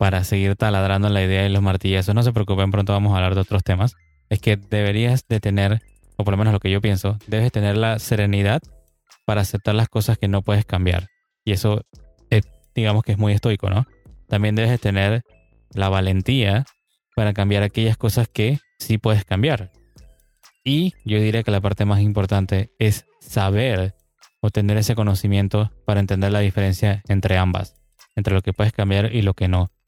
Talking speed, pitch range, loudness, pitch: 195 wpm, 100-110 Hz, -20 LUFS, 105 Hz